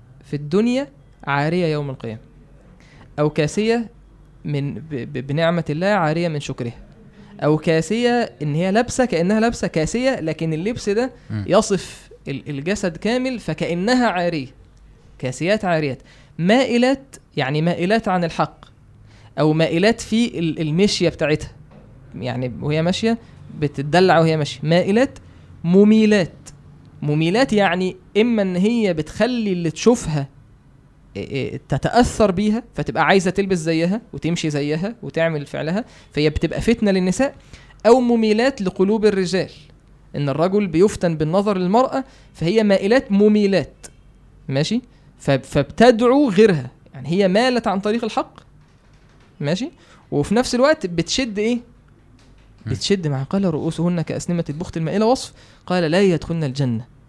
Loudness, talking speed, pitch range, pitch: -19 LUFS, 115 wpm, 145-210 Hz, 170 Hz